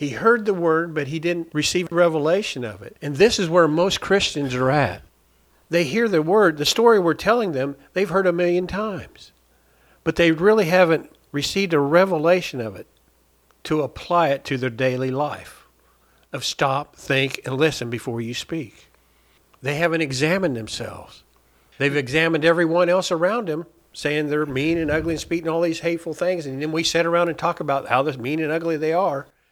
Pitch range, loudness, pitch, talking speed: 135-175 Hz, -21 LUFS, 160 Hz, 190 wpm